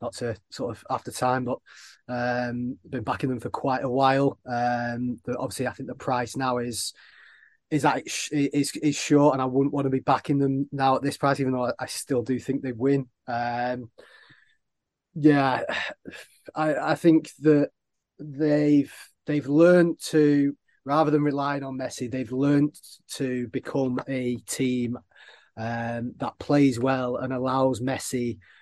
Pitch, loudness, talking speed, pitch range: 130 Hz, -25 LUFS, 170 wpm, 125-145 Hz